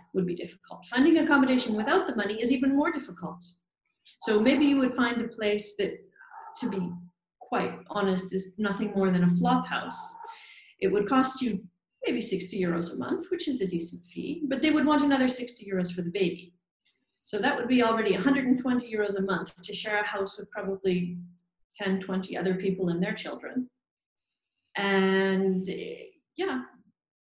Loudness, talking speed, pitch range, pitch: -28 LUFS, 175 wpm, 190-275 Hz, 210 Hz